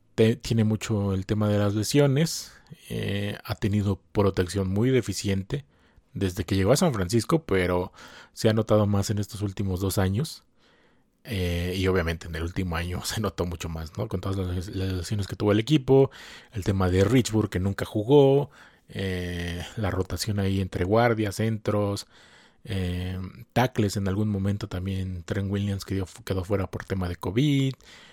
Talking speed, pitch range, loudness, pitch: 170 wpm, 95-110 Hz, -26 LUFS, 100 Hz